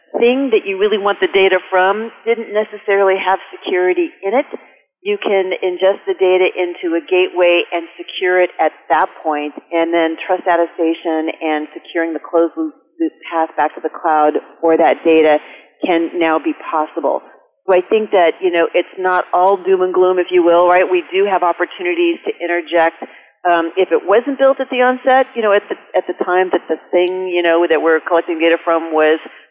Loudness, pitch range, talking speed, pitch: -15 LUFS, 165-195 Hz, 195 wpm, 180 Hz